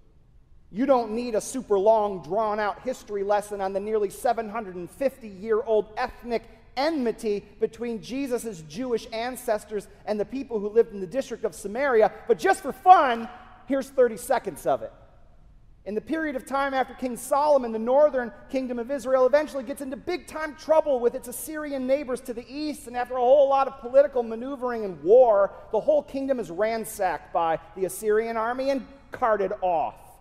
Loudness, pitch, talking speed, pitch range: -25 LUFS, 240 Hz, 175 wpm, 215-275 Hz